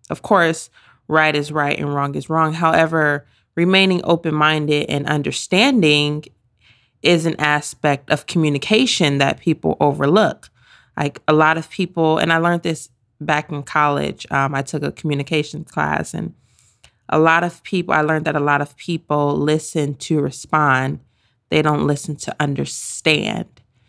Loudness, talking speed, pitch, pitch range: -18 LUFS, 155 wpm, 150 Hz, 145-160 Hz